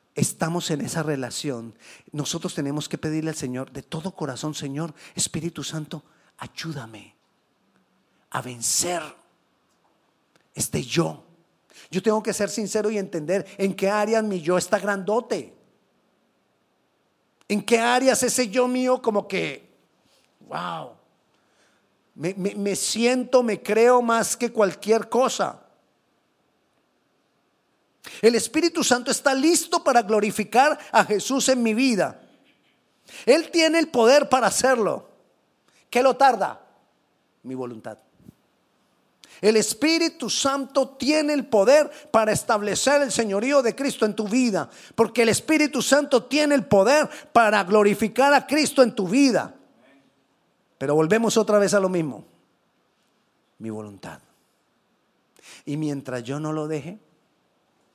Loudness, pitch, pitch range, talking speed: -22 LUFS, 215 Hz, 165-255 Hz, 125 wpm